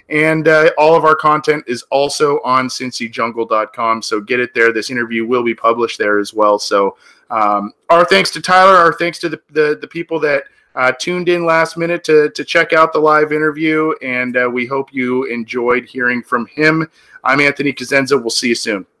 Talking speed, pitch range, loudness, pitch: 200 wpm, 120-160 Hz, -14 LUFS, 135 Hz